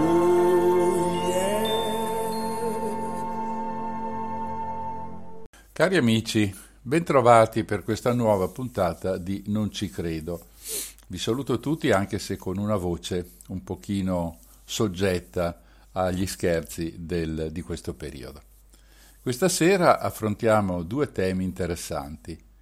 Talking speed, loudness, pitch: 90 wpm, -25 LUFS, 105 Hz